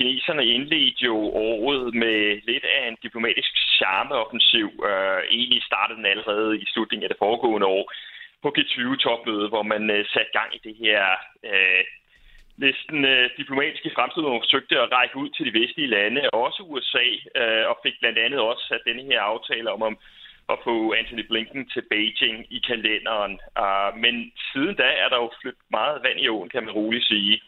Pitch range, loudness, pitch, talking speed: 110-135 Hz, -22 LUFS, 115 Hz, 185 wpm